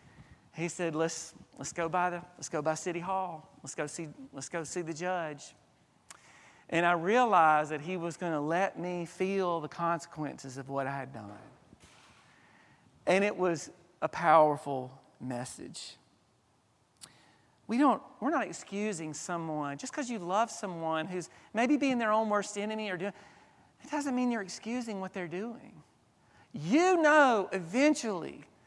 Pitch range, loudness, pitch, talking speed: 155-205 Hz, -31 LUFS, 175 Hz, 155 wpm